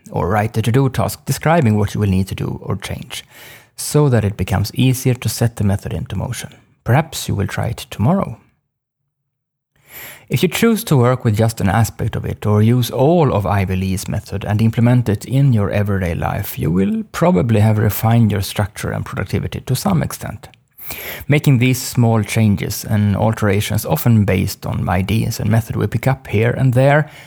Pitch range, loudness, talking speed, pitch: 105-130 Hz, -17 LUFS, 190 wpm, 115 Hz